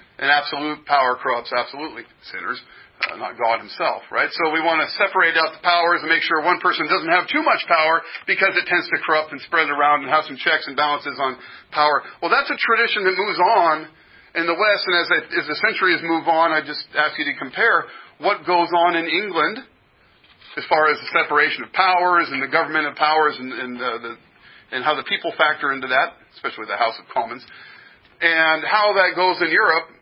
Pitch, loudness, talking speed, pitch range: 160 Hz, -19 LUFS, 215 wpm, 150-175 Hz